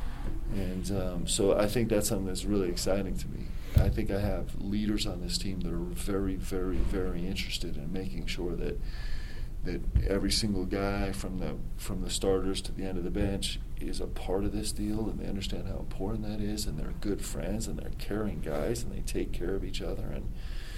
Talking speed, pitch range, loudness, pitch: 215 wpm, 90-100 Hz, -33 LUFS, 95 Hz